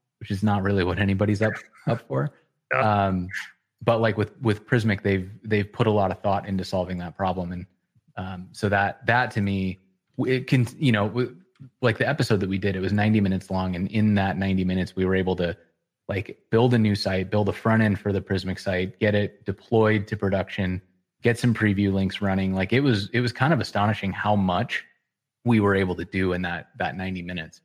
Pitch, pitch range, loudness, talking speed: 100 Hz, 95-110 Hz, -24 LUFS, 215 wpm